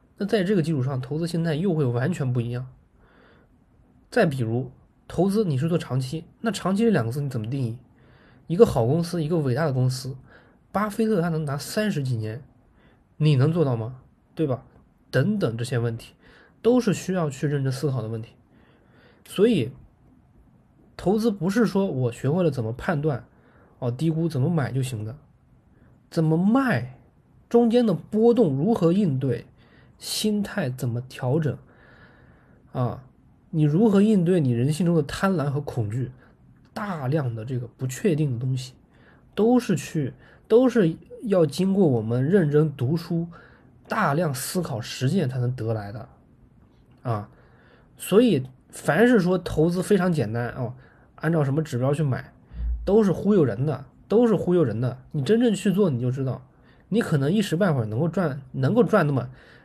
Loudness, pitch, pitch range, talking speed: -24 LUFS, 150 Hz, 125-185 Hz, 240 characters per minute